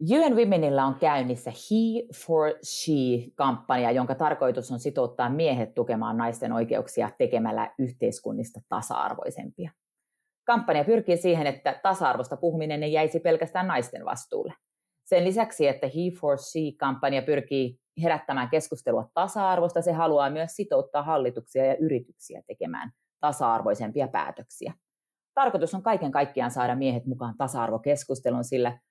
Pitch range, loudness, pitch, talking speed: 130-180 Hz, -27 LUFS, 150 Hz, 120 wpm